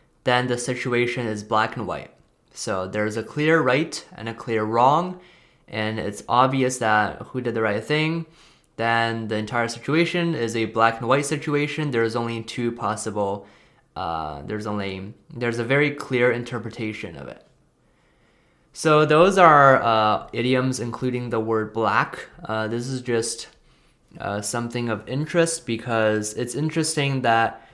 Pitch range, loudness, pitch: 110-135 Hz, -22 LUFS, 120 Hz